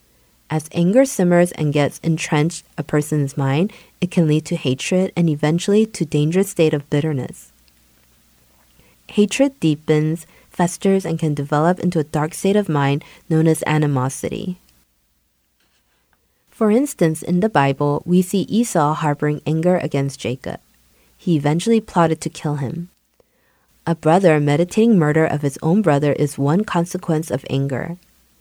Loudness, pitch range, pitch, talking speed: -18 LUFS, 140-175 Hz, 155 Hz, 140 wpm